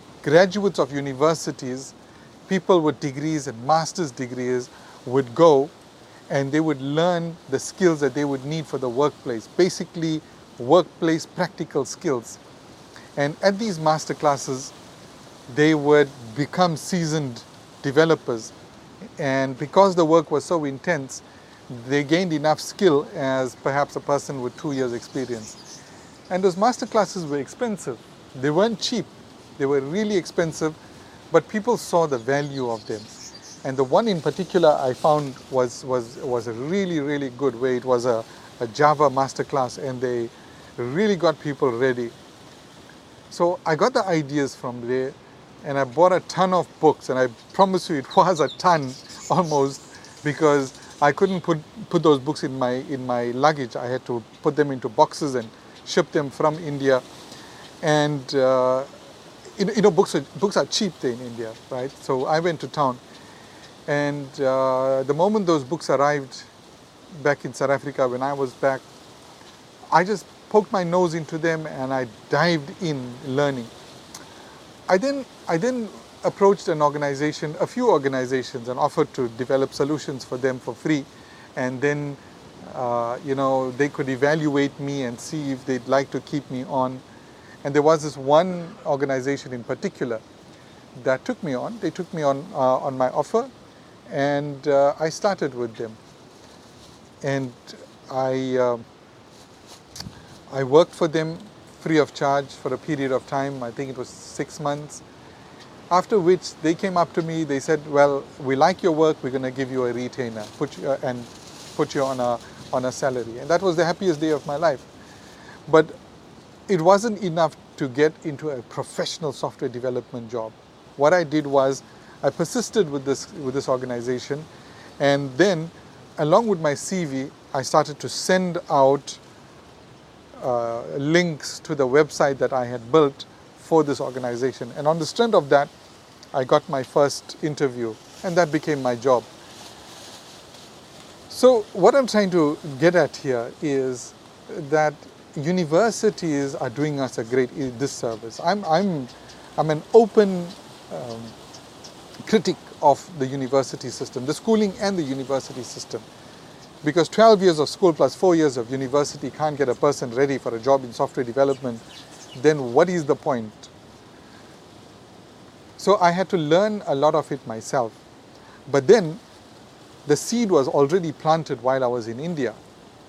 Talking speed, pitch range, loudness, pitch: 160 wpm, 130-165 Hz, -22 LUFS, 145 Hz